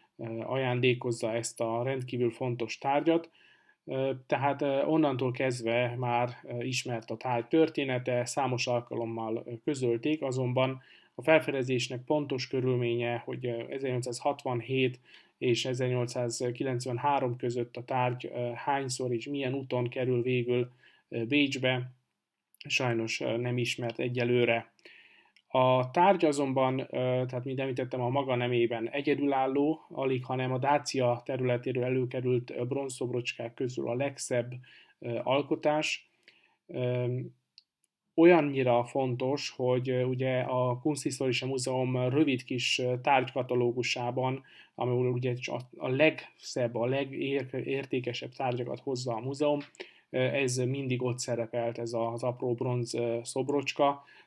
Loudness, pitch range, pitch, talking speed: -30 LUFS, 120-135 Hz, 125 Hz, 100 wpm